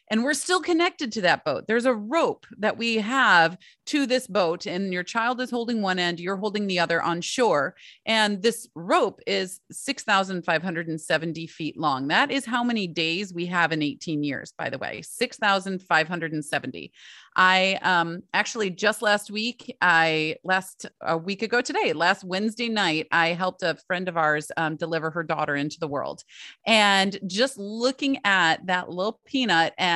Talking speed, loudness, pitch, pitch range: 170 wpm, -24 LUFS, 190 Hz, 165-225 Hz